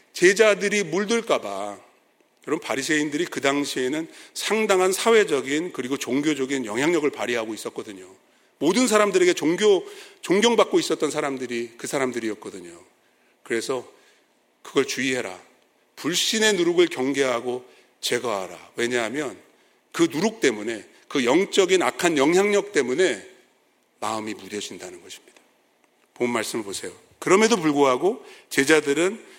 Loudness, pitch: -22 LUFS, 175 Hz